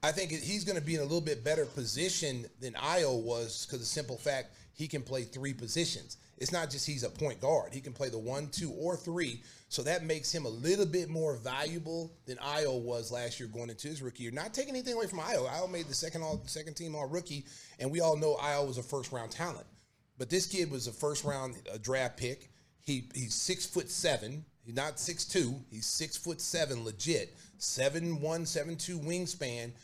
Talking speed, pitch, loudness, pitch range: 225 wpm, 145 Hz, -35 LUFS, 125-165 Hz